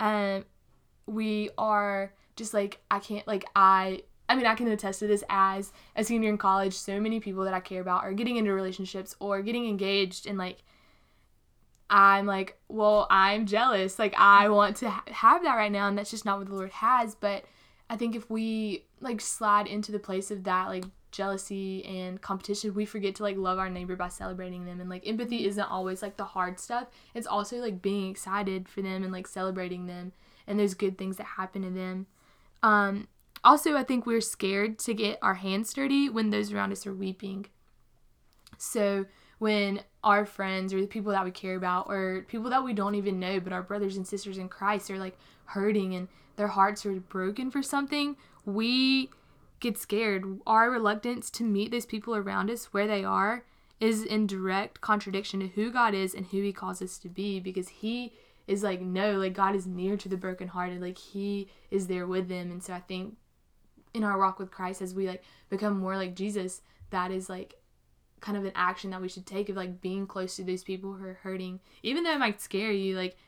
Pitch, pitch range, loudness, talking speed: 195 Hz, 190-210 Hz, -29 LUFS, 210 wpm